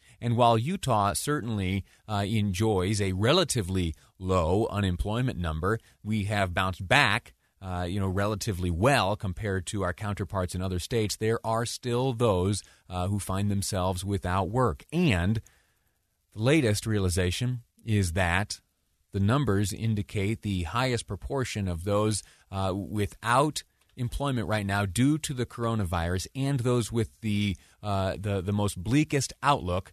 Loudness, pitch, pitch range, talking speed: -28 LUFS, 105 Hz, 95-115 Hz, 140 wpm